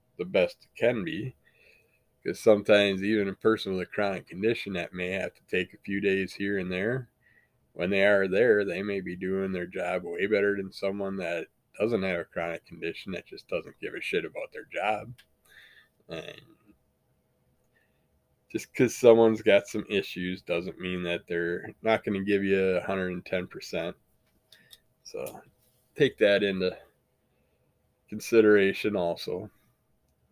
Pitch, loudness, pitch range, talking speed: 100 Hz, -28 LUFS, 95-110 Hz, 150 wpm